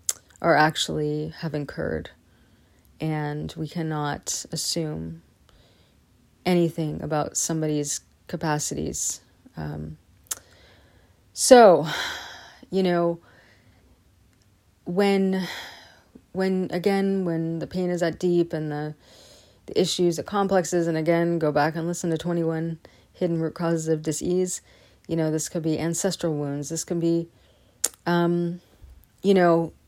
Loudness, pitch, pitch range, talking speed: -24 LUFS, 160 Hz, 105-170 Hz, 115 wpm